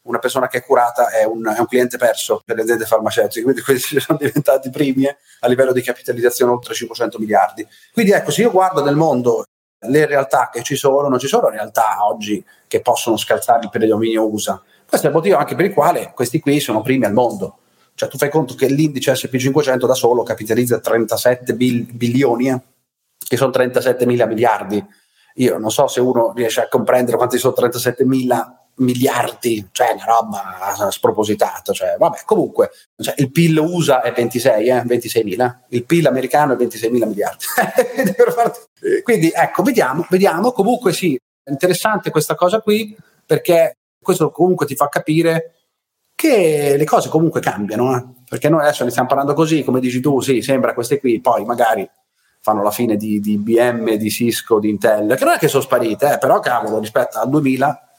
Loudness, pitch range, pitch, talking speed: -16 LUFS, 120-165 Hz, 130 Hz, 185 wpm